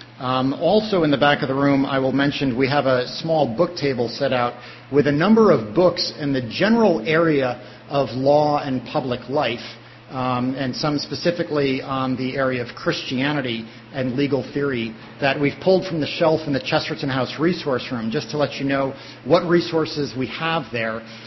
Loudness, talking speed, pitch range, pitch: -21 LUFS, 190 wpm, 125-155 Hz, 140 Hz